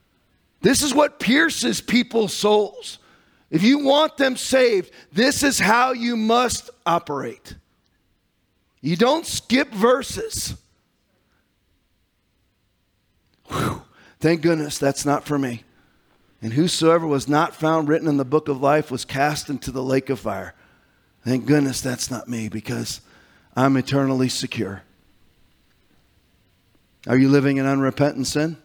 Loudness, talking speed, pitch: -20 LUFS, 130 wpm, 140 Hz